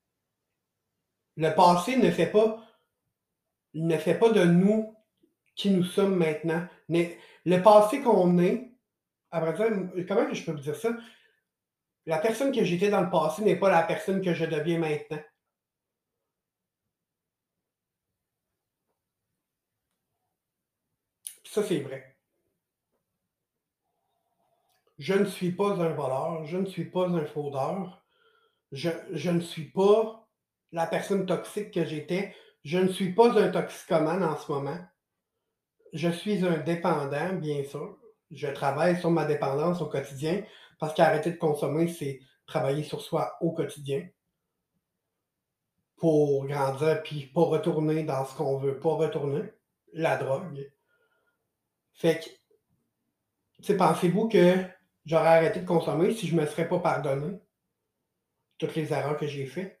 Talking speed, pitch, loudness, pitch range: 135 wpm, 170 Hz, -27 LUFS, 155-195 Hz